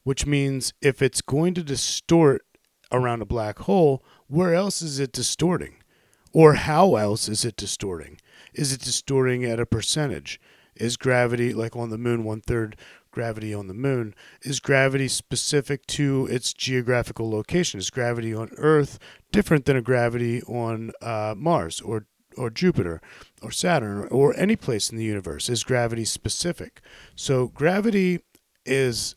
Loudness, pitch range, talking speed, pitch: -23 LUFS, 110-140 Hz, 155 wpm, 125 Hz